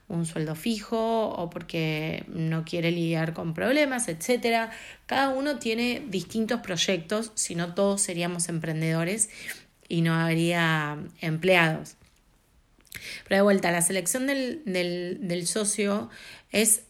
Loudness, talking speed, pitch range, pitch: -26 LUFS, 125 wpm, 170-225 Hz, 180 Hz